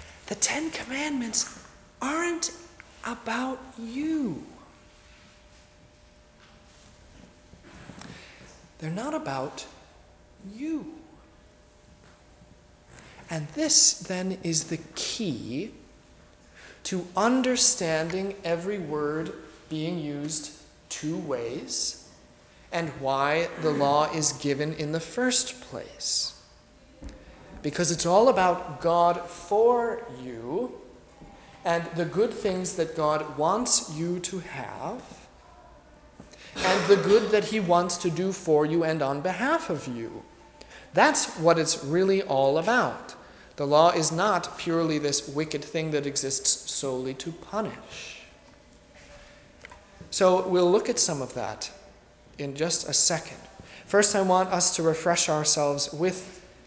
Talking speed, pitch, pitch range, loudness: 110 wpm, 170 Hz, 150-195 Hz, -25 LUFS